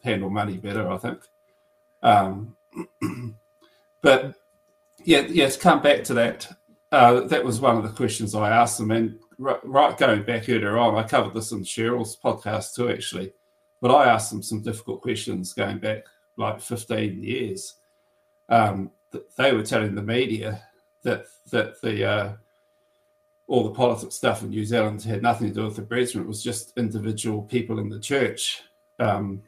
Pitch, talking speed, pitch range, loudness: 115 Hz, 170 wpm, 110-150 Hz, -23 LUFS